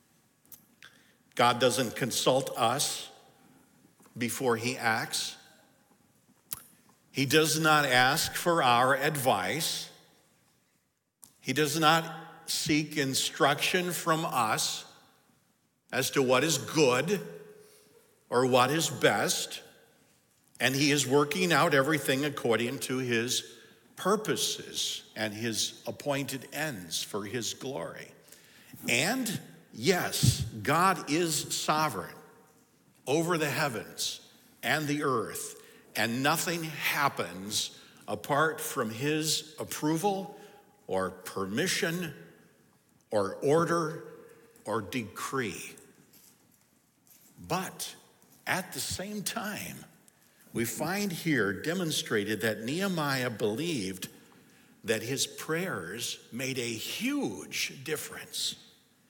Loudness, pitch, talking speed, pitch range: -29 LUFS, 150 Hz, 90 wpm, 125-165 Hz